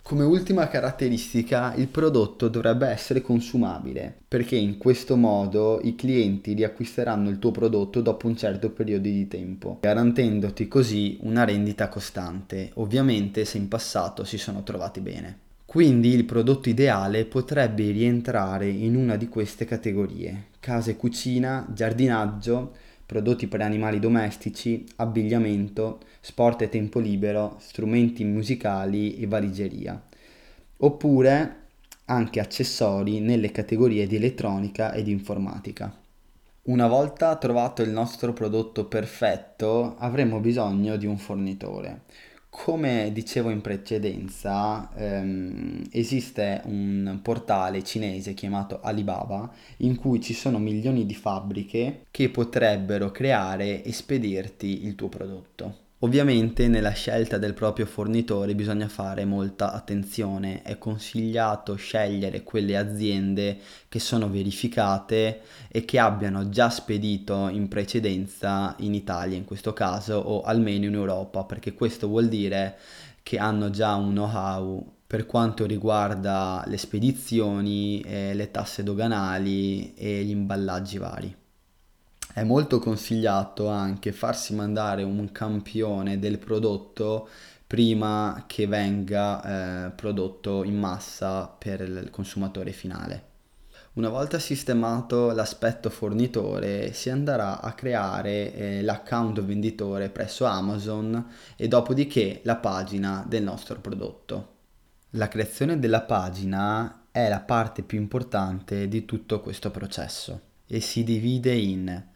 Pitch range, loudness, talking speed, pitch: 100-115 Hz, -26 LUFS, 120 wpm, 105 Hz